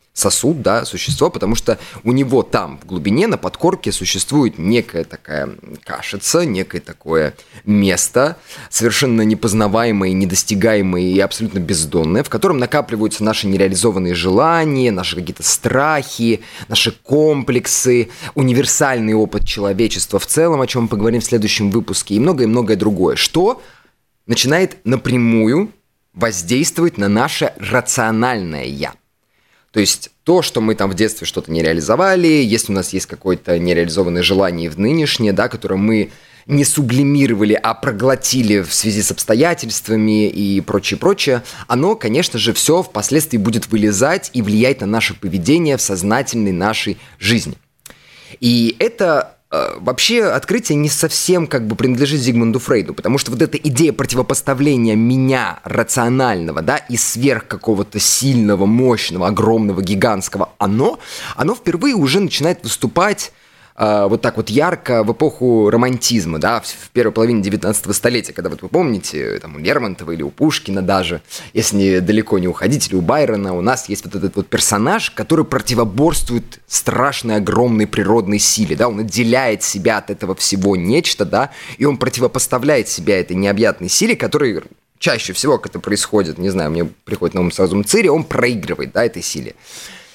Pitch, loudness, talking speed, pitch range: 115 Hz, -15 LUFS, 150 wpm, 100-130 Hz